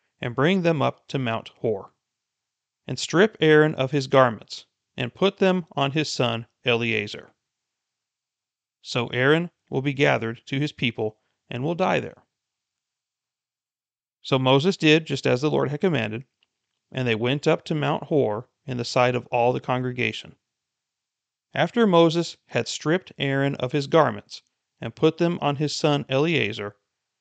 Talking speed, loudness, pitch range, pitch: 155 wpm, -23 LUFS, 120-155 Hz, 135 Hz